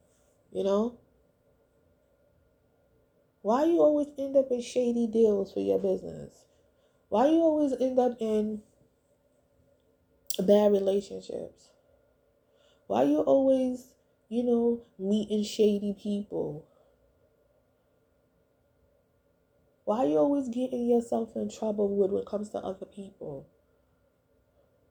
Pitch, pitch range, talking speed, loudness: 220 Hz, 200-255 Hz, 105 wpm, -28 LUFS